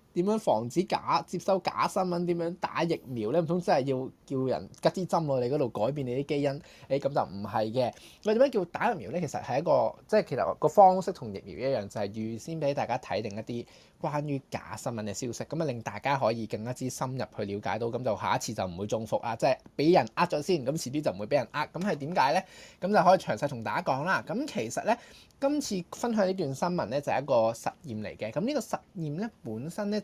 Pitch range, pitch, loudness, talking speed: 115-175 Hz, 140 Hz, -30 LUFS, 355 characters per minute